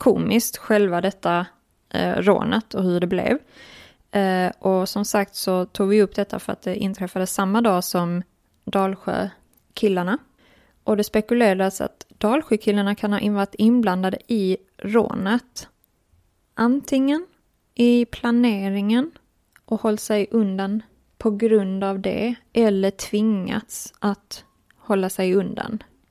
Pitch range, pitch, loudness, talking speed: 190-225 Hz, 205 Hz, -22 LUFS, 125 wpm